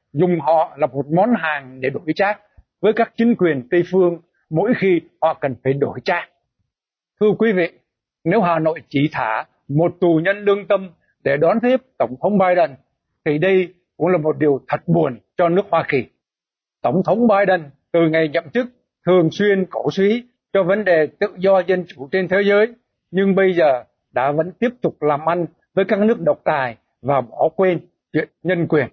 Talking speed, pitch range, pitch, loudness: 195 wpm, 160-195 Hz, 175 Hz, -18 LUFS